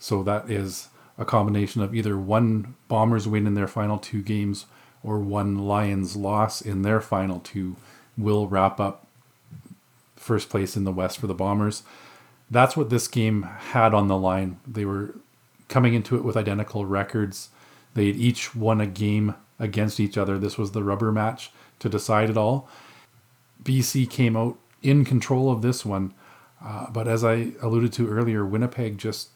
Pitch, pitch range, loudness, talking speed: 110 Hz, 100-120 Hz, -24 LUFS, 175 wpm